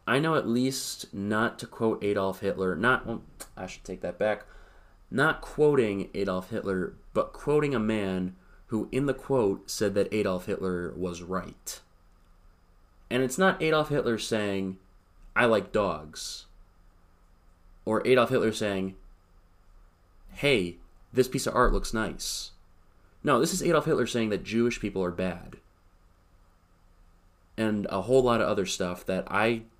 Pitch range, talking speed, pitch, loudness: 90-115 Hz, 150 wpm, 95 Hz, -28 LUFS